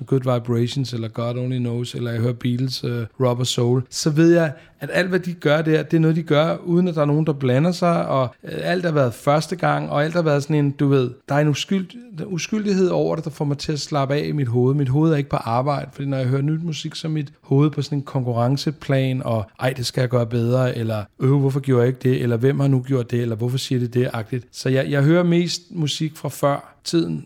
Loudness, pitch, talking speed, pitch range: -21 LUFS, 140 Hz, 270 wpm, 125-155 Hz